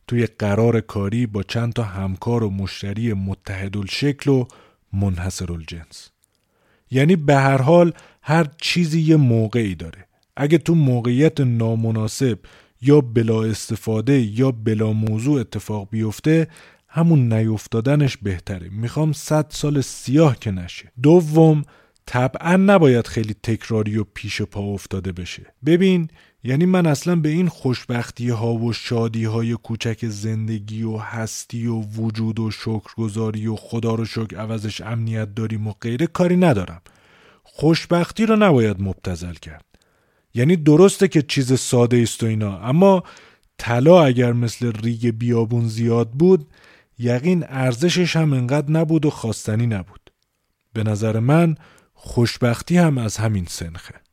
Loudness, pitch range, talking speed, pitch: -19 LUFS, 110-145 Hz, 135 wpm, 115 Hz